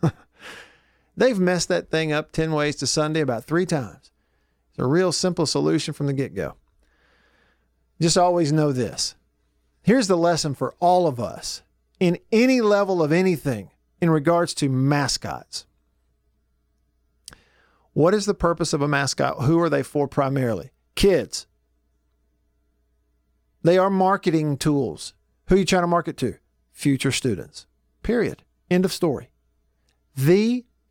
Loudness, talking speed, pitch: -22 LUFS, 140 wpm, 140 Hz